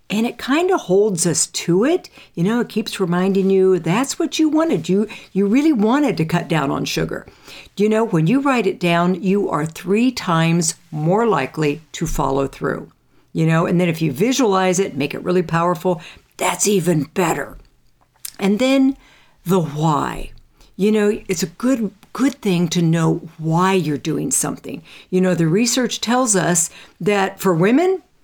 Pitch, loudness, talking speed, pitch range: 190 Hz, -18 LUFS, 180 wpm, 170-220 Hz